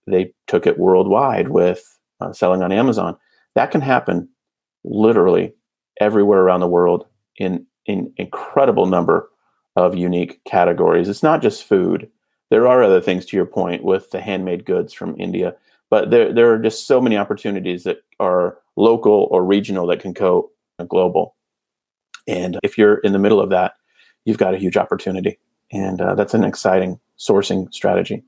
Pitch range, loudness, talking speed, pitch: 90-105 Hz, -17 LUFS, 170 wpm, 95 Hz